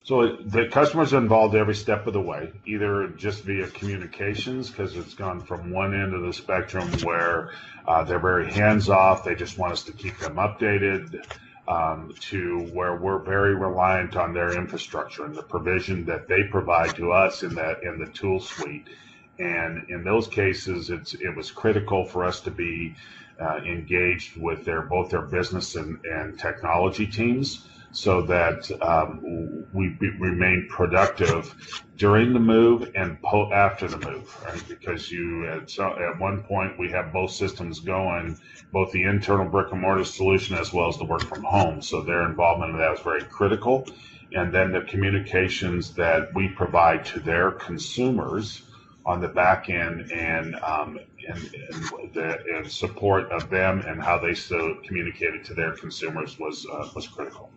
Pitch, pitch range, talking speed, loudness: 95 Hz, 85-100 Hz, 175 wpm, -24 LUFS